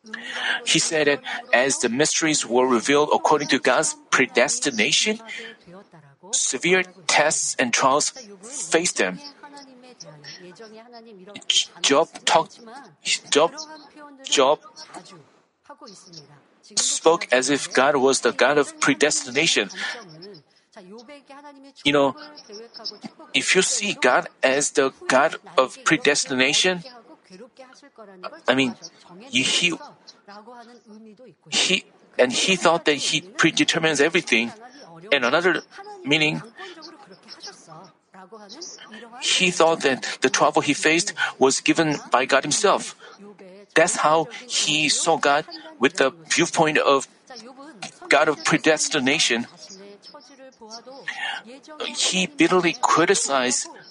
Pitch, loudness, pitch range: 195 Hz, -20 LUFS, 155-250 Hz